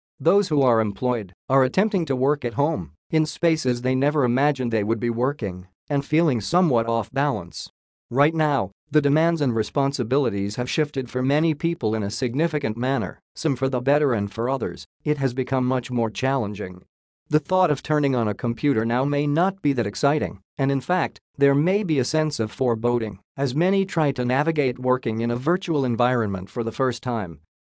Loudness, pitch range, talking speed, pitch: -23 LUFS, 120-150 Hz, 195 wpm, 135 Hz